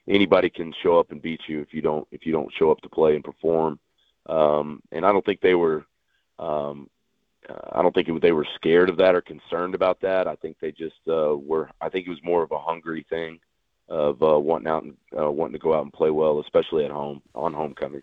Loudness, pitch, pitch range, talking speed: -23 LUFS, 80 Hz, 75-80 Hz, 245 wpm